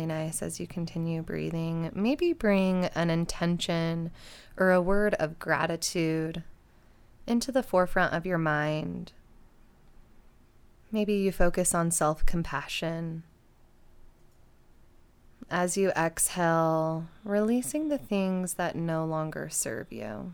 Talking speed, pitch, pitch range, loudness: 110 wpm, 170 Hz, 160-190 Hz, -29 LUFS